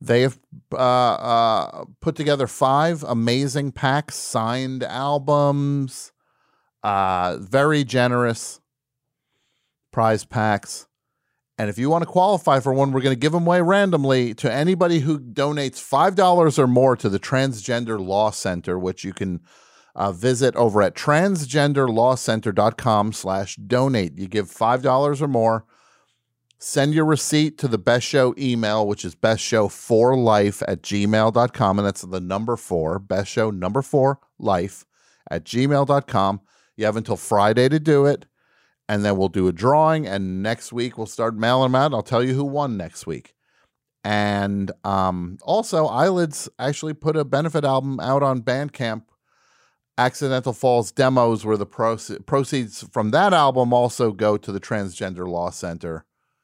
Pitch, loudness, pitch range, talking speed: 125 Hz, -20 LUFS, 105-140 Hz, 150 wpm